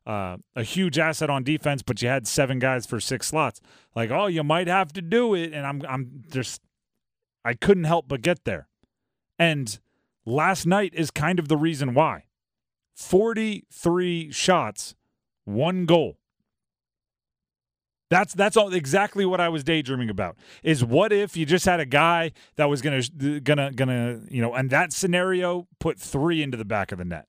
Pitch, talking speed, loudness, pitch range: 155 Hz, 180 wpm, -24 LUFS, 130-175 Hz